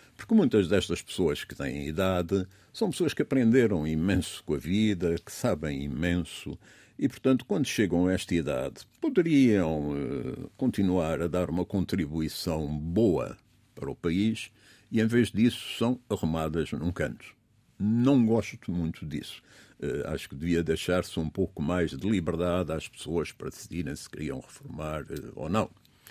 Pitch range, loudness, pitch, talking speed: 80-105 Hz, -29 LUFS, 90 Hz, 155 wpm